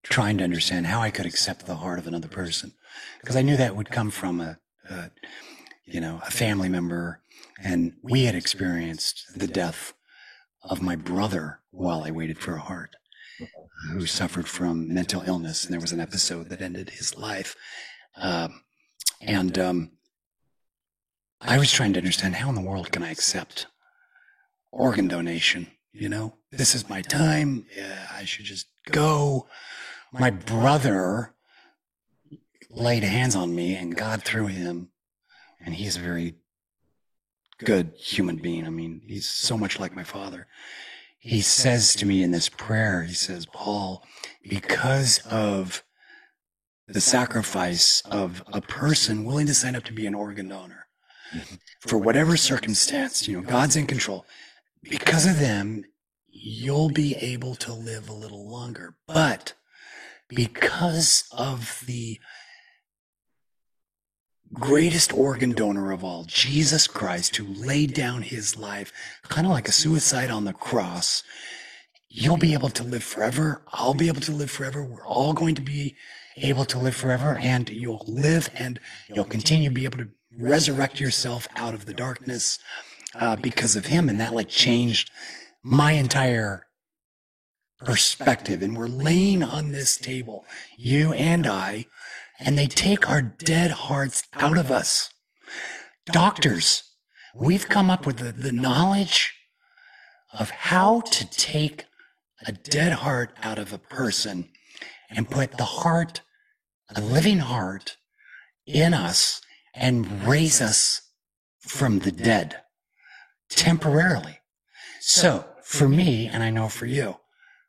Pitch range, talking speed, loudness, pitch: 100-140 Hz, 145 wpm, -23 LUFS, 120 Hz